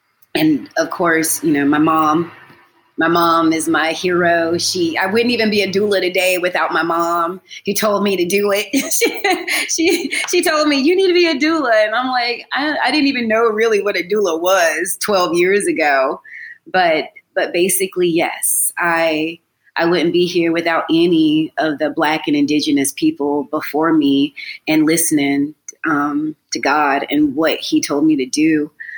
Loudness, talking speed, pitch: -16 LUFS, 180 wpm, 200 Hz